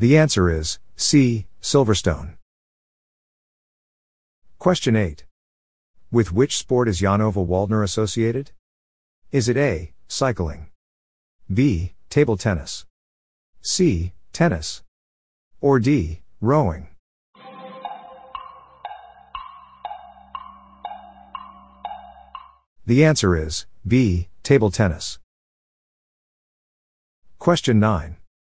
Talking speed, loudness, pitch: 70 wpm, -20 LUFS, 105 Hz